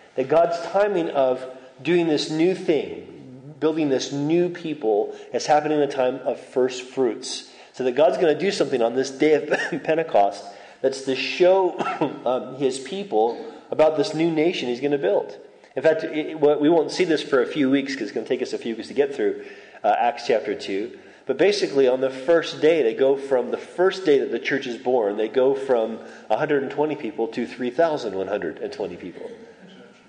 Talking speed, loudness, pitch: 195 wpm, -22 LUFS, 155 Hz